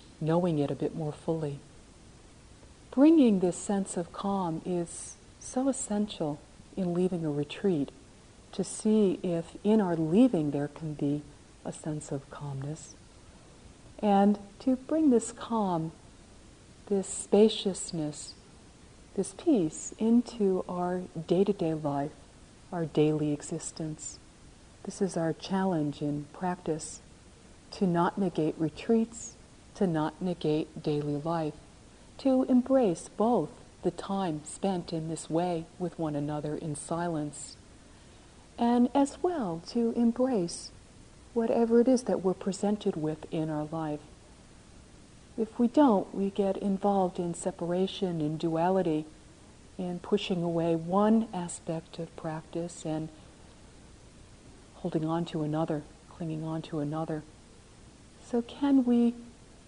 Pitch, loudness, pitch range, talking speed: 175 Hz, -30 LUFS, 155-200 Hz, 125 wpm